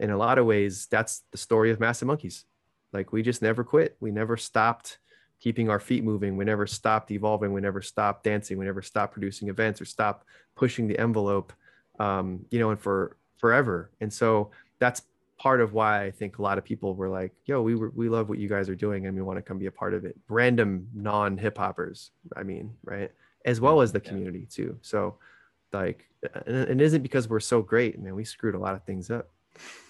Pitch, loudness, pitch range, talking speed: 105 Hz, -27 LUFS, 100-115 Hz, 225 wpm